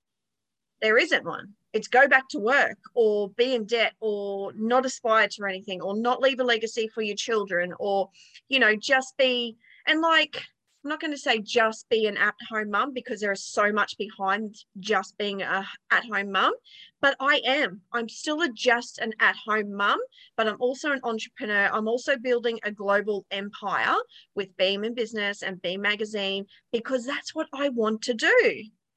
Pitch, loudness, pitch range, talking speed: 220 Hz, -25 LUFS, 205-260 Hz, 185 wpm